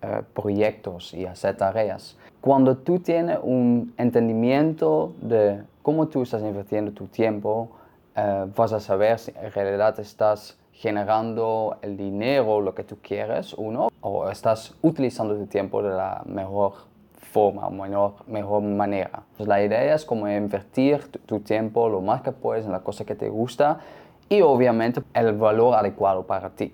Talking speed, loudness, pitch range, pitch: 165 wpm, -24 LUFS, 100-120 Hz, 110 Hz